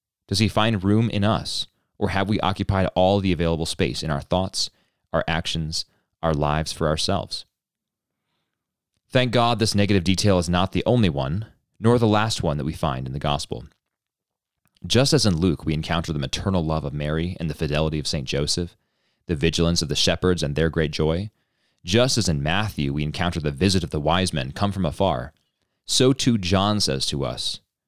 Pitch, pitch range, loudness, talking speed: 90 Hz, 80-100 Hz, -22 LUFS, 195 wpm